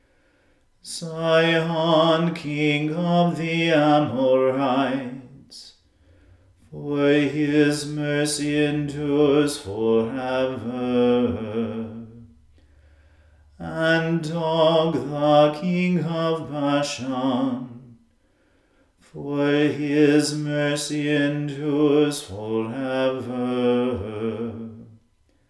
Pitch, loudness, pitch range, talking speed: 145 Hz, -22 LUFS, 115-150 Hz, 50 wpm